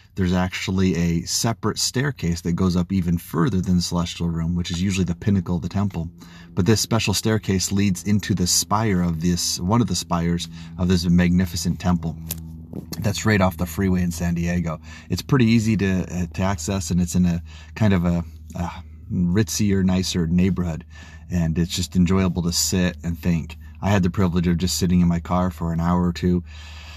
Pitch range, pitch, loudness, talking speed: 85-95 Hz, 90 Hz, -22 LUFS, 205 wpm